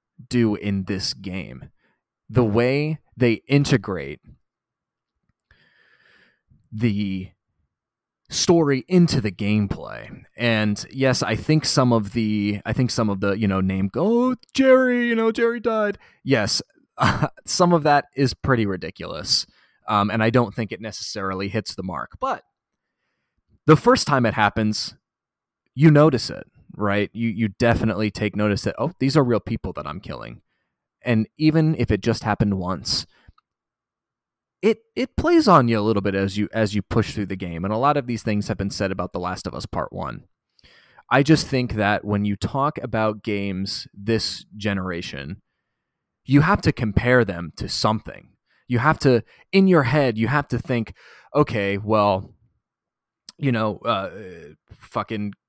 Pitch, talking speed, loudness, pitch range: 115 Hz, 160 wpm, -21 LUFS, 100-140 Hz